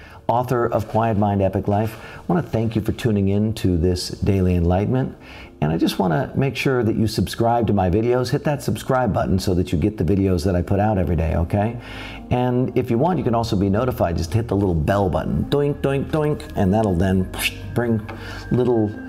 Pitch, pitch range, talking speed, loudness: 110 Hz, 95-120 Hz, 225 wpm, -20 LUFS